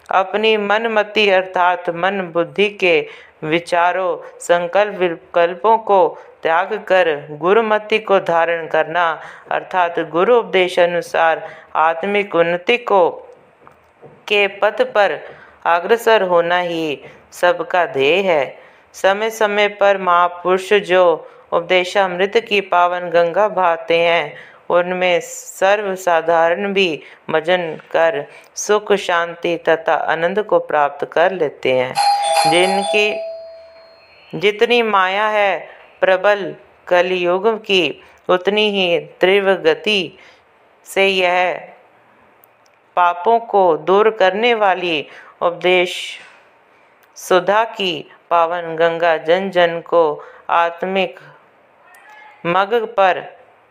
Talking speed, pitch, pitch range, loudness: 95 wpm, 185 Hz, 170-210 Hz, -16 LUFS